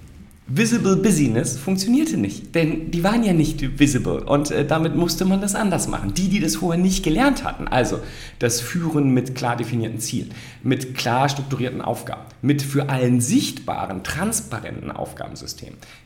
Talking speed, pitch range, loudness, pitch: 155 wpm, 125-180 Hz, -21 LUFS, 145 Hz